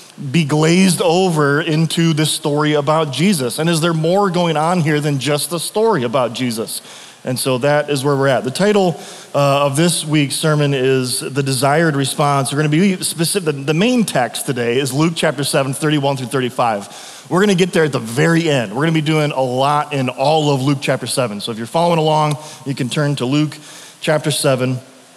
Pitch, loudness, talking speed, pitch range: 150 Hz, -16 LUFS, 210 wpm, 140-165 Hz